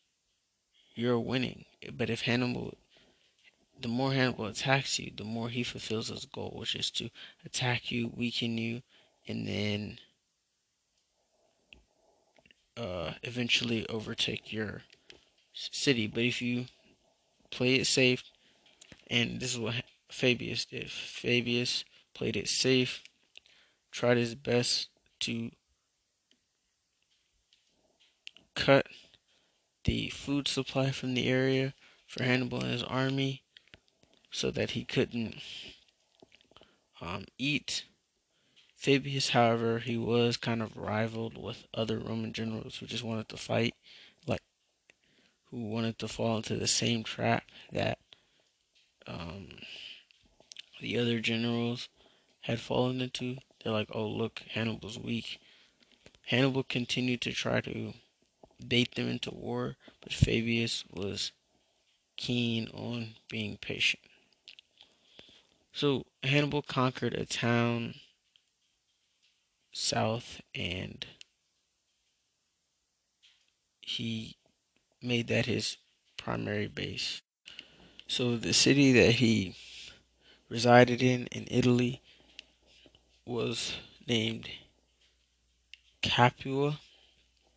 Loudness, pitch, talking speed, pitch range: -31 LUFS, 120 Hz, 100 wpm, 110-125 Hz